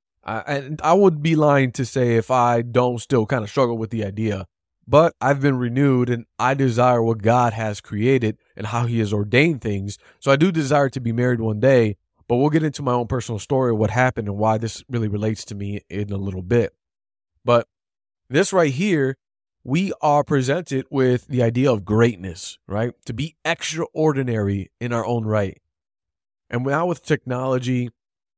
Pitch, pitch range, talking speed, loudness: 120 Hz, 110-135 Hz, 190 wpm, -21 LUFS